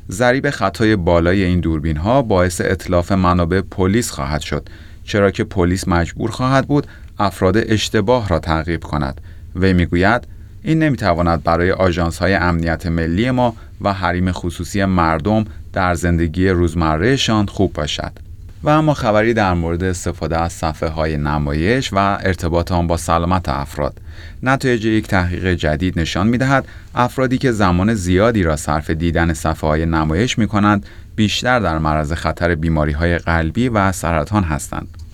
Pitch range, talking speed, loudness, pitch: 85-105 Hz, 150 wpm, -17 LUFS, 90 Hz